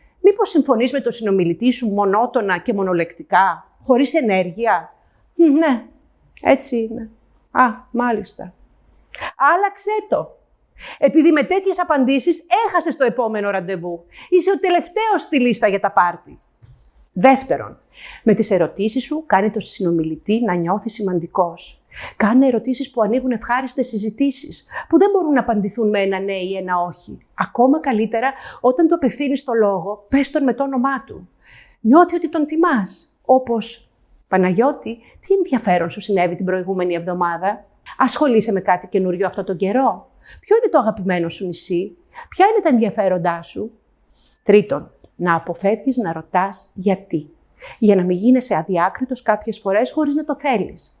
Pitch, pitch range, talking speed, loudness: 230 Hz, 190-275 Hz, 145 wpm, -18 LUFS